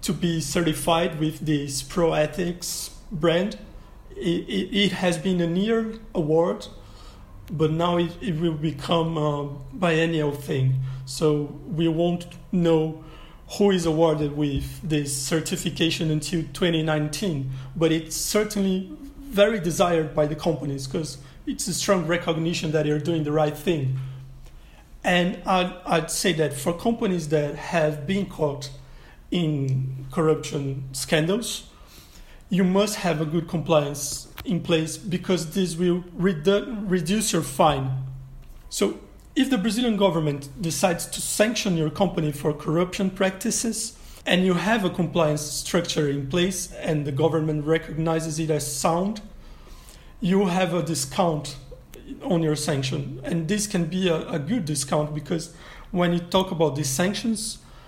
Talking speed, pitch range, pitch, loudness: 140 wpm, 150-185 Hz, 165 Hz, -24 LUFS